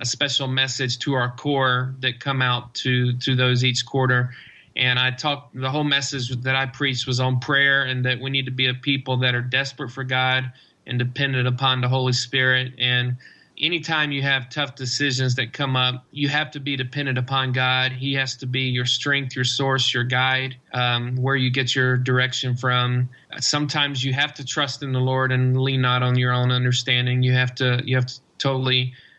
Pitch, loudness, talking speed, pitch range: 130 Hz, -21 LUFS, 205 wpm, 125-135 Hz